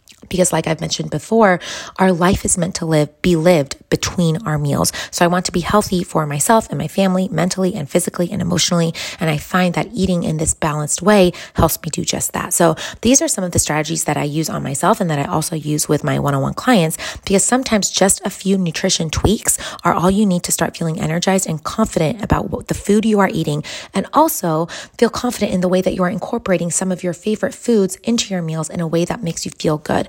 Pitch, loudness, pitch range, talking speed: 180 Hz, -17 LUFS, 160-195 Hz, 240 wpm